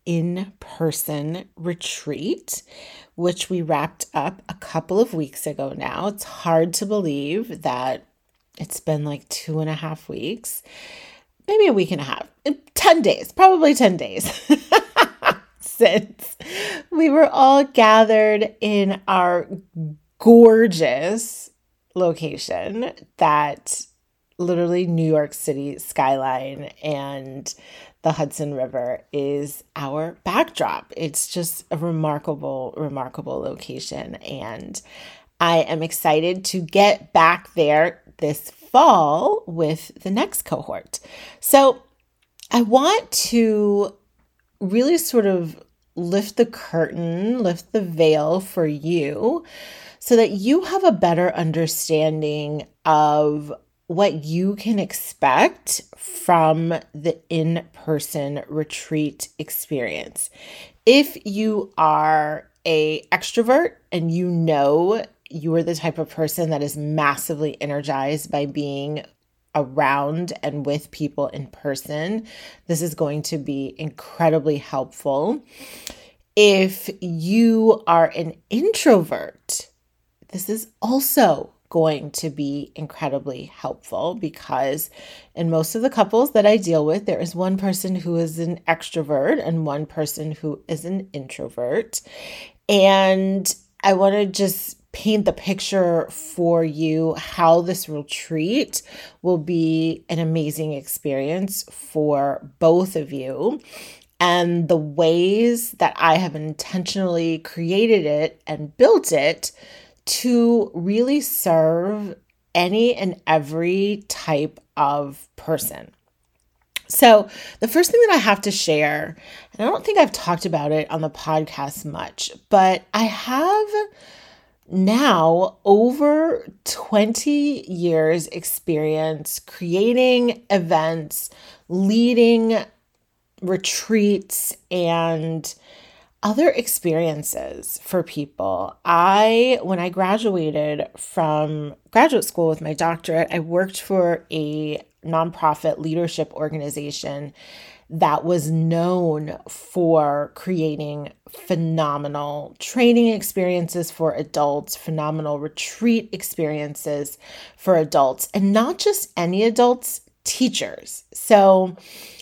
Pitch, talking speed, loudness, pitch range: 170 Hz, 110 wpm, -20 LUFS, 155-205 Hz